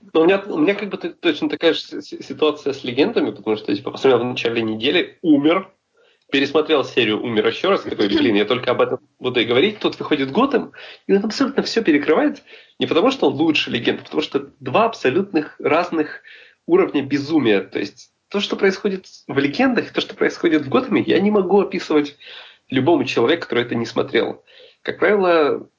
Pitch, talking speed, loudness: 195 Hz, 190 wpm, -19 LUFS